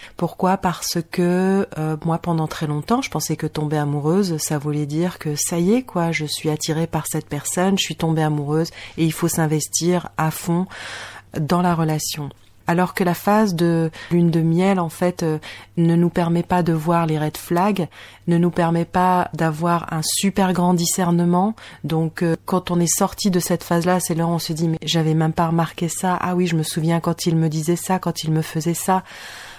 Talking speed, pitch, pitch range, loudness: 215 wpm, 170 Hz, 160-180 Hz, -20 LUFS